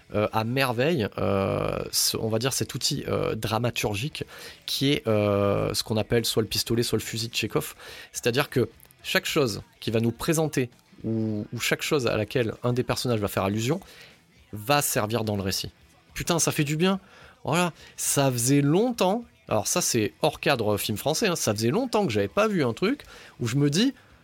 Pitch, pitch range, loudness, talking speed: 120 Hz, 110-150 Hz, -25 LUFS, 200 wpm